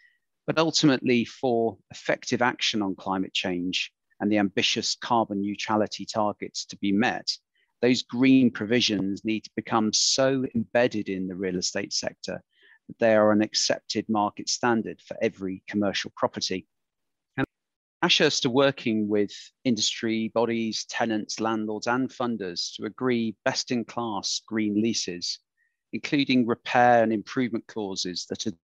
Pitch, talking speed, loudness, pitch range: 110 Hz, 135 wpm, -26 LUFS, 100-120 Hz